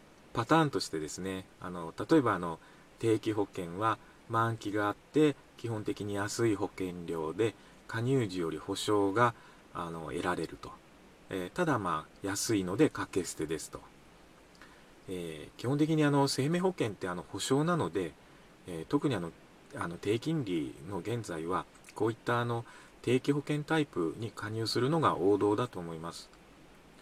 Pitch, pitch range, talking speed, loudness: 110 Hz, 90-135 Hz, 290 characters per minute, -33 LUFS